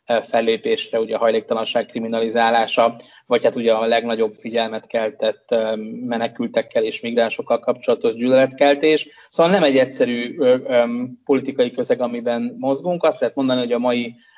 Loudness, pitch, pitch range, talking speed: -19 LUFS, 120 Hz, 115-135 Hz, 130 wpm